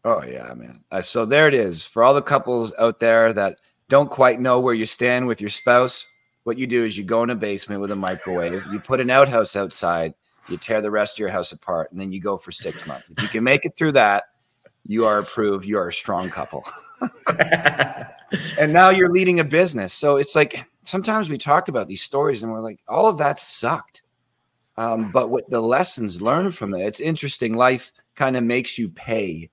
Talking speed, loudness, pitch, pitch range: 220 wpm, -20 LUFS, 120 Hz, 105-140 Hz